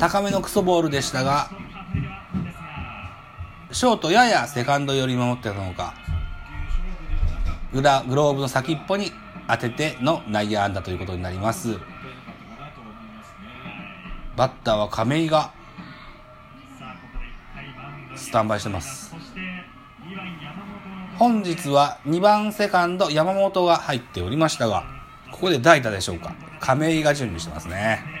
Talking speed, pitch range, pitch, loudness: 250 characters per minute, 105-170 Hz, 140 Hz, -22 LUFS